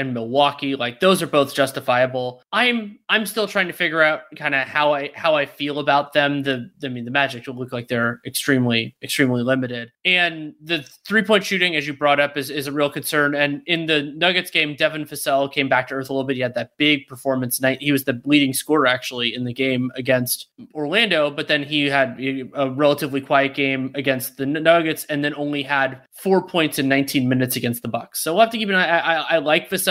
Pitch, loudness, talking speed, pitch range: 145 Hz, -20 LUFS, 230 wpm, 130-155 Hz